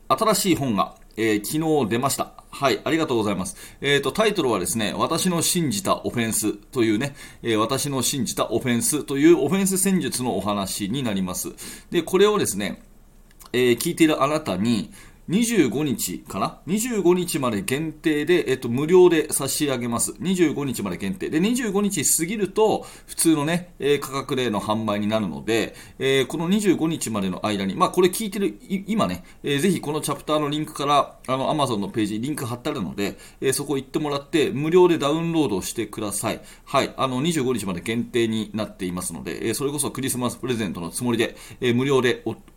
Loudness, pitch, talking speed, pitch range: -23 LUFS, 140 Hz, 380 characters per minute, 115-170 Hz